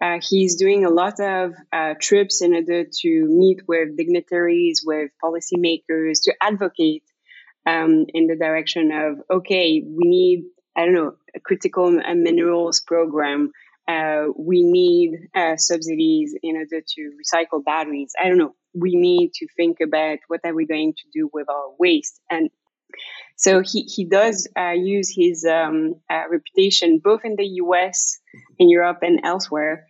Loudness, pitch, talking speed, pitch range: -19 LUFS, 170 Hz, 160 wpm, 160-195 Hz